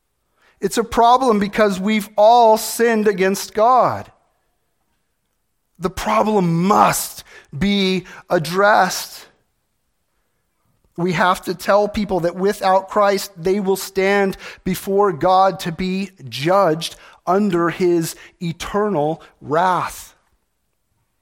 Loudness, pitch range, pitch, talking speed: -17 LUFS, 175-205 Hz, 190 Hz, 95 wpm